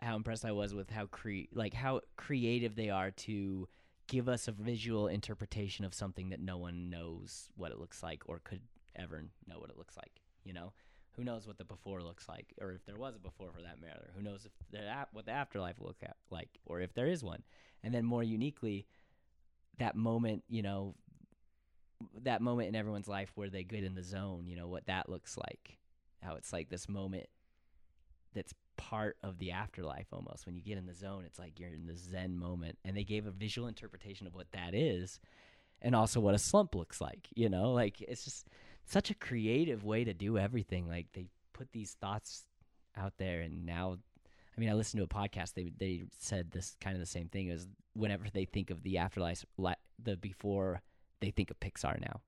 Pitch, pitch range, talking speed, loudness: 95 Hz, 90-110 Hz, 215 wpm, -40 LUFS